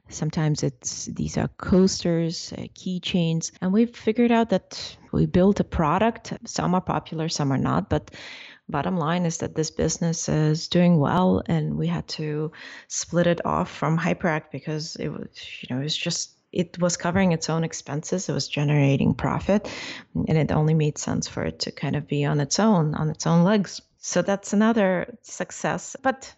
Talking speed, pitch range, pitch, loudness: 185 wpm, 155-185 Hz, 170 Hz, -24 LUFS